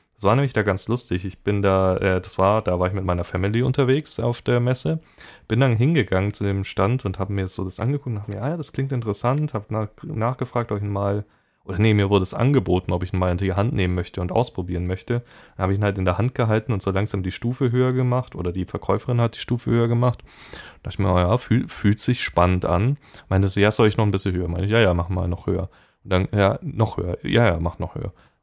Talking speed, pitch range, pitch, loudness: 265 wpm, 95-120 Hz, 105 Hz, -22 LUFS